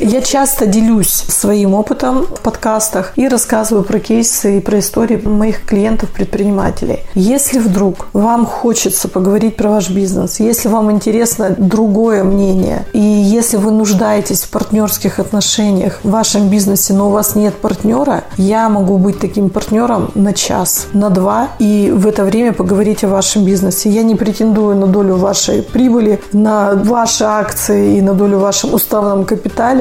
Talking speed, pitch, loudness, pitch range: 155 wpm, 210 Hz, -12 LUFS, 195-220 Hz